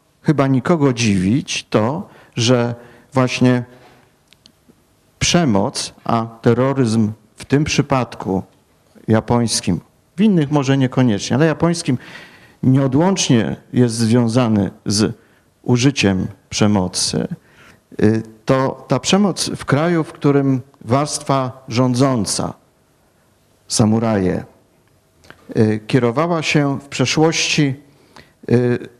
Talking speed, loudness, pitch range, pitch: 80 wpm, -17 LUFS, 110-140 Hz, 125 Hz